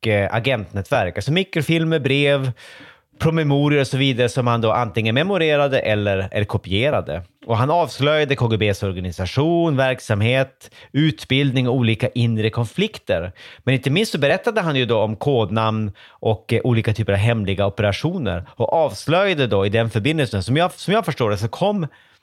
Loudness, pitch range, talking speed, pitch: -19 LUFS, 110-145 Hz, 150 wpm, 125 Hz